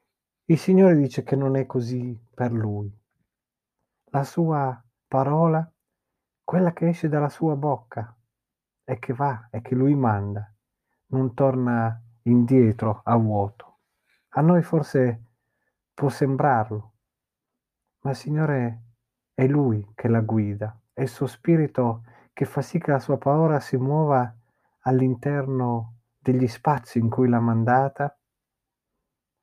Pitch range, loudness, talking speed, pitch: 115-140 Hz, -23 LUFS, 130 wpm, 130 Hz